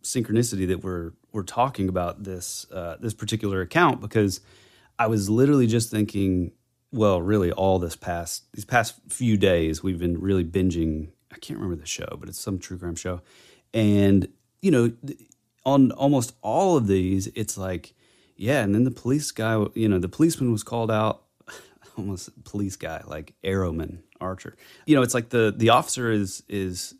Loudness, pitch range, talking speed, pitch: -24 LUFS, 95-115 Hz, 175 wpm, 105 Hz